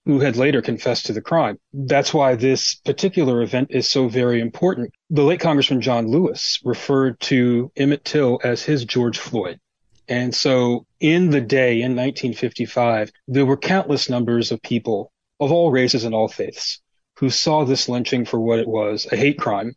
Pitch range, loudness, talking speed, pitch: 120-140 Hz, -19 LUFS, 180 wpm, 130 Hz